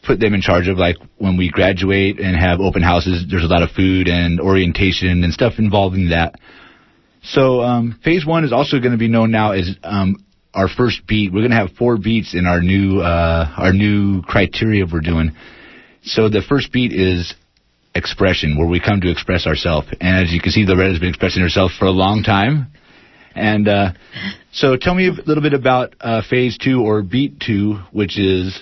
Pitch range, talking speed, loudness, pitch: 90-110 Hz, 205 wpm, -16 LUFS, 95 Hz